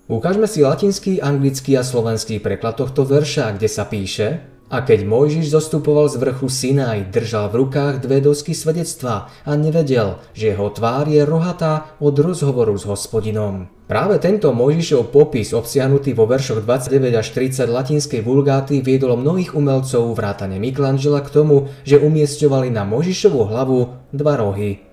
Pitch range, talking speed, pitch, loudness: 115-150 Hz, 150 wpm, 135 Hz, -17 LUFS